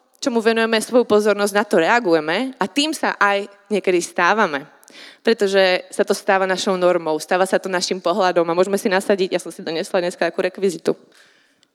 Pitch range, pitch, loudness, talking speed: 180-210 Hz, 195 Hz, -19 LUFS, 180 wpm